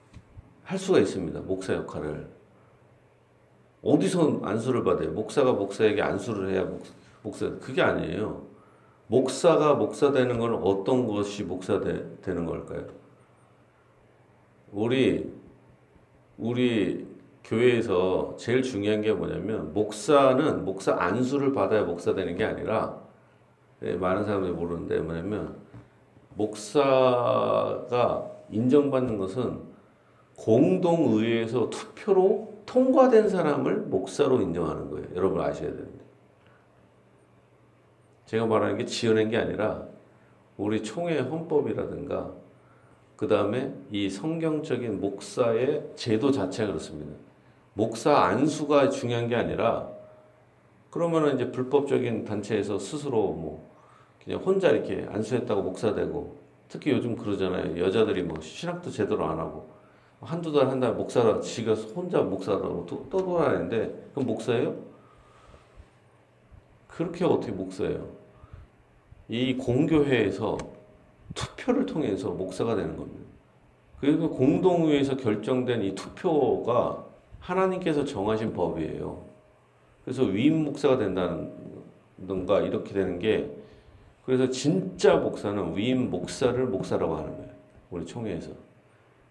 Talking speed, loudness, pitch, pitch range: 275 characters per minute, -26 LUFS, 115 Hz, 100-145 Hz